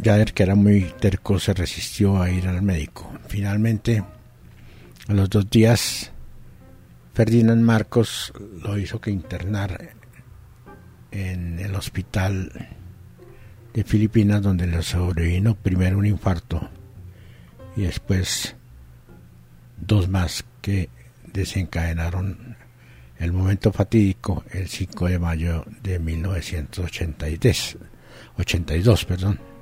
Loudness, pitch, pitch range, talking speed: -22 LUFS, 95 Hz, 90-105 Hz, 100 wpm